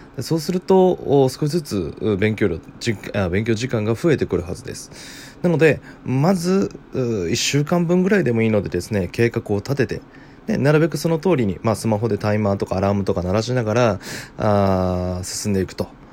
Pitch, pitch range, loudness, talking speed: 115 Hz, 100-150 Hz, -20 LUFS, 340 characters per minute